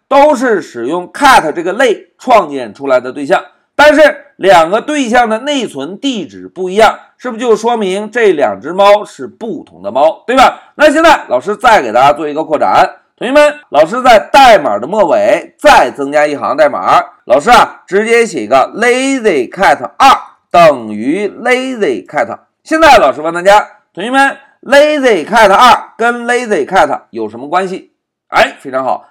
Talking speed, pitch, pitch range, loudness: 290 characters per minute, 250 Hz, 205-295 Hz, -9 LUFS